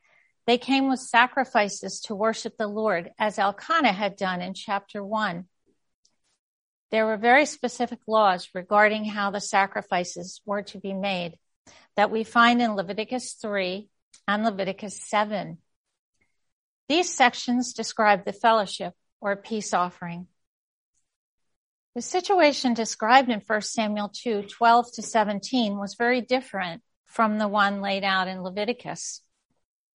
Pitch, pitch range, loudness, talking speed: 215 Hz, 200-240 Hz, -24 LUFS, 130 wpm